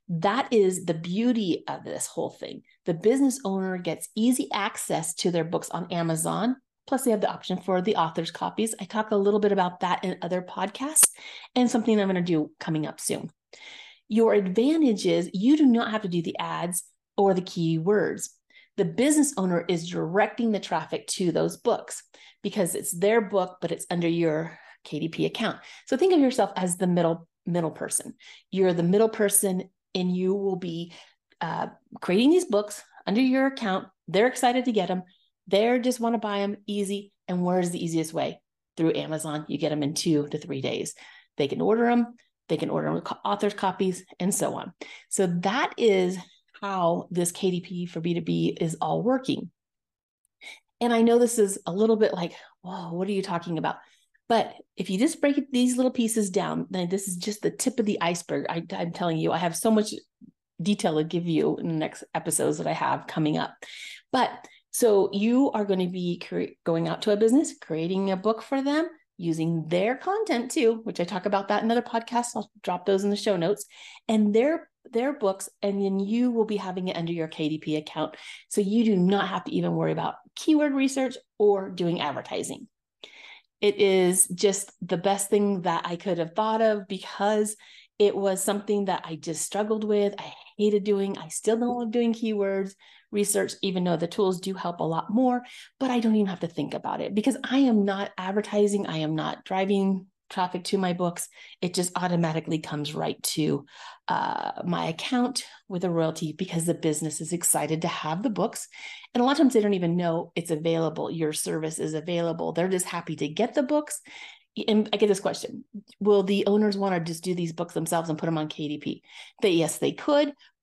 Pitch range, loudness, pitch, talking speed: 175-225 Hz, -26 LUFS, 195 Hz, 205 wpm